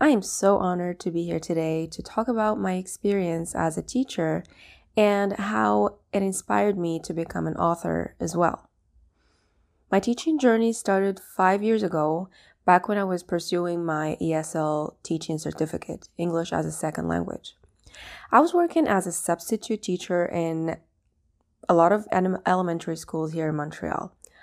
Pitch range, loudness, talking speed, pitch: 160-200 Hz, -25 LUFS, 155 wpm, 175 Hz